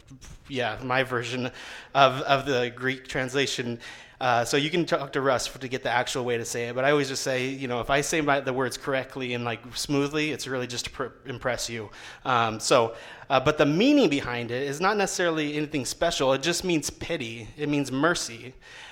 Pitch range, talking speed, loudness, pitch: 125-150 Hz, 220 wpm, -26 LUFS, 135 Hz